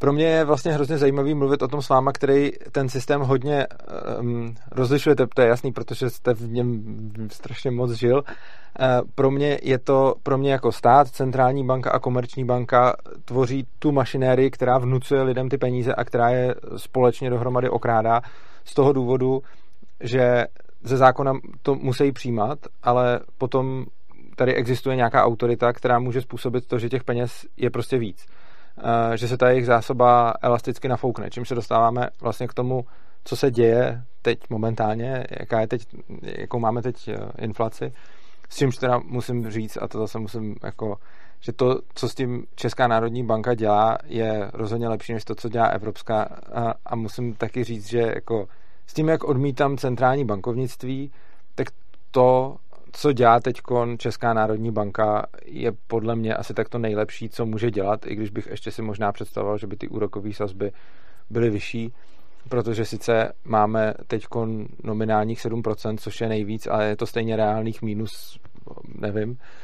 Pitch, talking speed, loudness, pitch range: 120 Hz, 165 wpm, -23 LUFS, 110-130 Hz